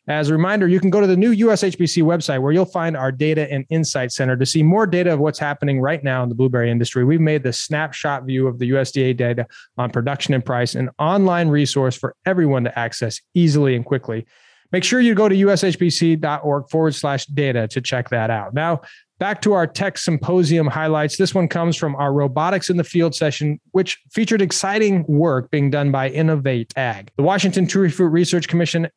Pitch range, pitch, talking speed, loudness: 135-175 Hz, 155 Hz, 205 wpm, -18 LUFS